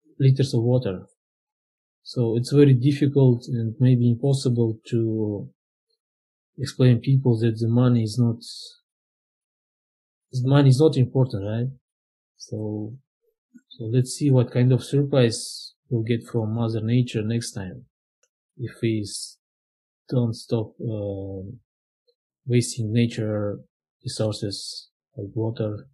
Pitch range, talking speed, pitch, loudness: 110-135 Hz, 115 wpm, 120 Hz, -23 LUFS